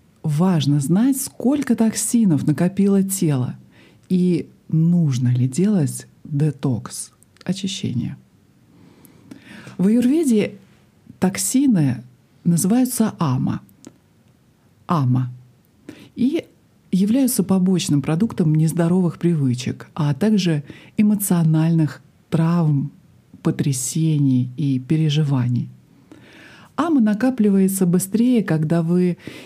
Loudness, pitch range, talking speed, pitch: -19 LUFS, 145-200 Hz, 75 wpm, 170 Hz